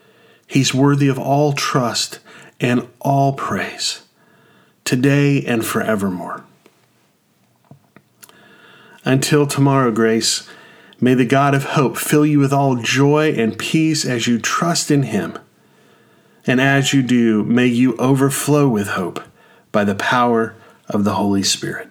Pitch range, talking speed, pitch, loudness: 115-140 Hz, 130 wpm, 135 Hz, -17 LUFS